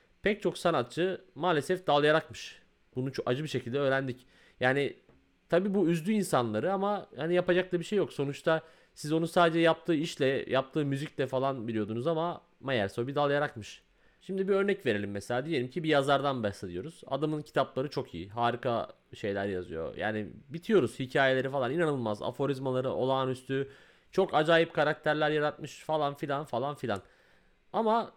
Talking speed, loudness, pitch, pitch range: 150 wpm, -30 LUFS, 145 Hz, 125-165 Hz